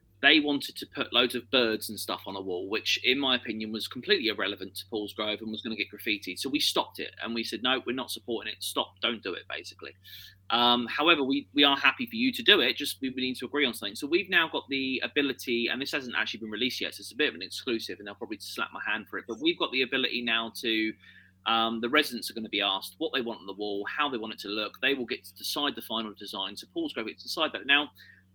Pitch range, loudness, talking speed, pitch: 105-135 Hz, -28 LUFS, 280 wpm, 115 Hz